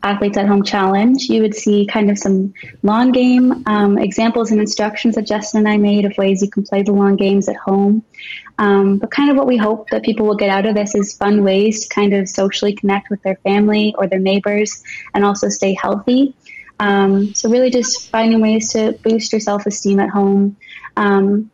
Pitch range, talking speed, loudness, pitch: 200-220 Hz, 215 wpm, -15 LUFS, 205 Hz